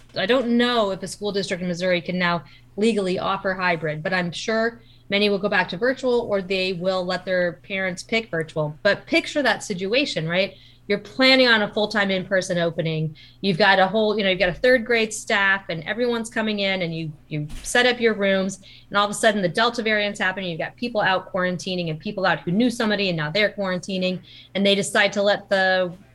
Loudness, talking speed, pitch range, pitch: -22 LUFS, 220 wpm, 180-210 Hz, 195 Hz